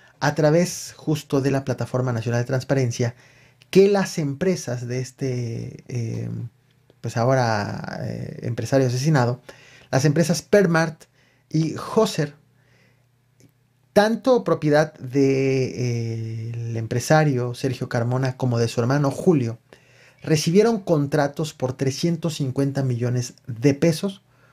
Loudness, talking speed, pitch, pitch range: -22 LUFS, 110 wpm, 135 Hz, 125-155 Hz